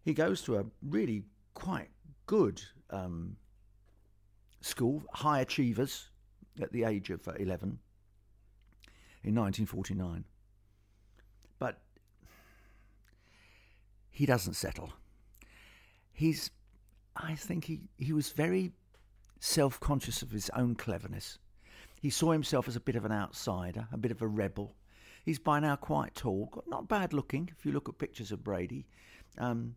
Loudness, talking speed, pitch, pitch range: -35 LUFS, 135 wpm, 105 Hz, 100-130 Hz